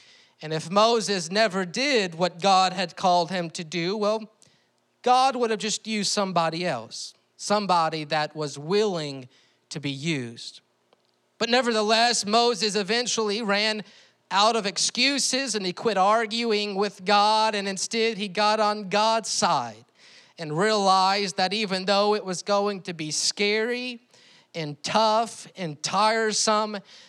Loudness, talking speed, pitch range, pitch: -24 LUFS, 140 wpm, 175-220 Hz, 205 Hz